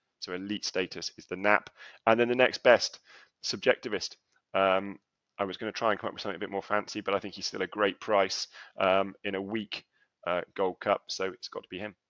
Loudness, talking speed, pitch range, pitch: -30 LUFS, 240 wpm, 95-110 Hz, 100 Hz